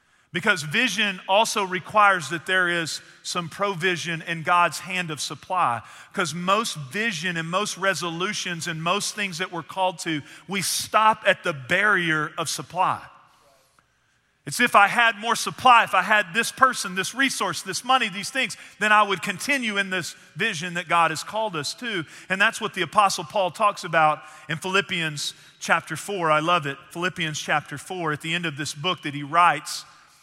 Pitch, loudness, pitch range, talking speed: 185 Hz, -23 LUFS, 165-205 Hz, 180 wpm